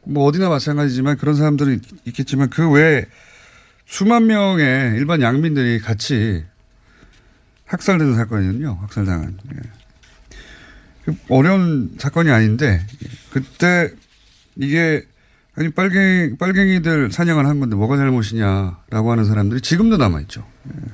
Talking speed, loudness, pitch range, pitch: 280 characters per minute, -17 LUFS, 110-155 Hz, 135 Hz